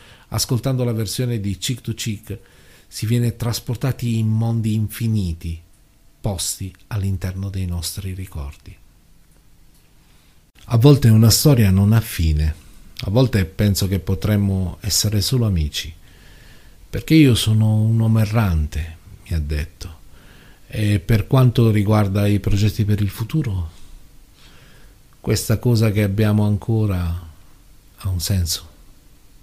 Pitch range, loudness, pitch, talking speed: 90-115 Hz, -19 LUFS, 105 Hz, 120 wpm